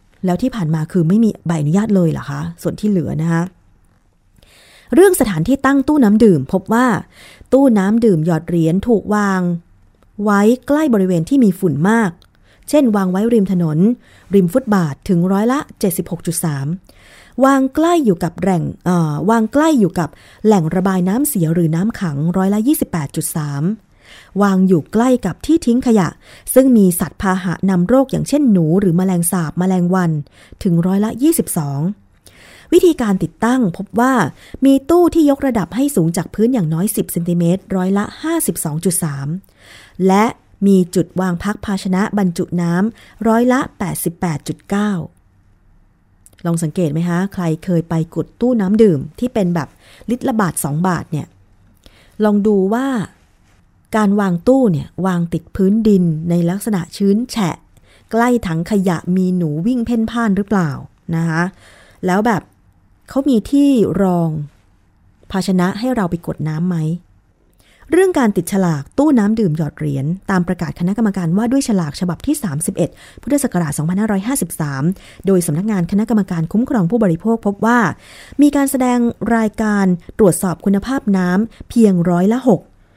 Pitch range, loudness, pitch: 170-225 Hz, -16 LUFS, 190 Hz